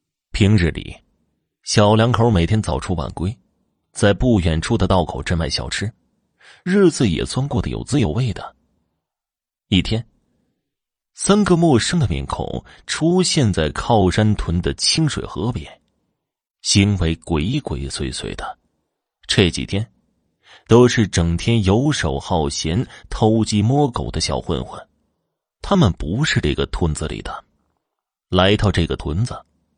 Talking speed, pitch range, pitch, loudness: 195 characters per minute, 85-120 Hz, 105 Hz, -18 LUFS